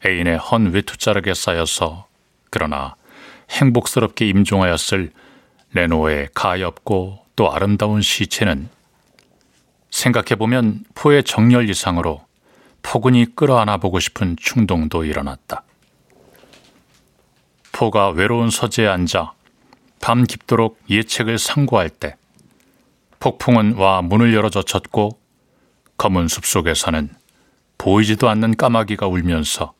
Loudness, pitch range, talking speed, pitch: -17 LUFS, 90-115 Hz, 245 characters per minute, 105 Hz